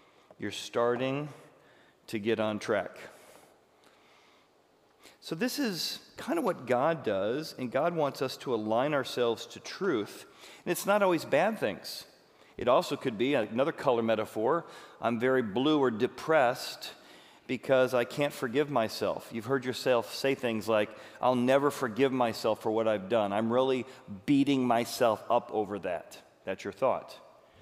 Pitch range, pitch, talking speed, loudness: 115-140 Hz, 125 Hz, 150 wpm, -30 LUFS